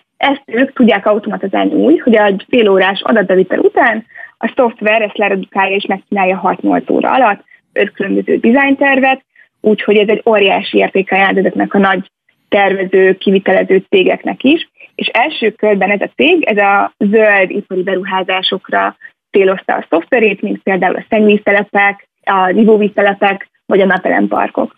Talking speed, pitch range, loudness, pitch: 140 wpm, 190-225 Hz, -12 LUFS, 205 Hz